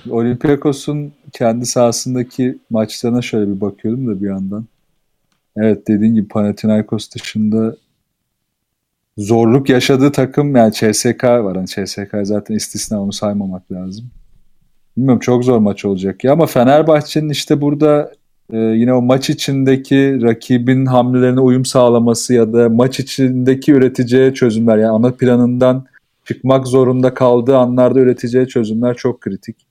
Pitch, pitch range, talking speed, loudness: 125 Hz, 110-130 Hz, 130 wpm, -13 LUFS